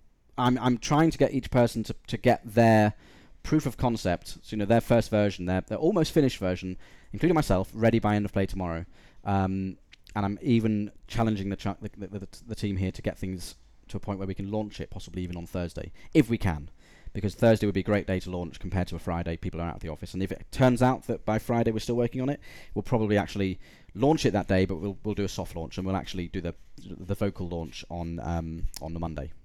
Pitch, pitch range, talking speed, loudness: 100 Hz, 90-115 Hz, 250 wpm, -28 LUFS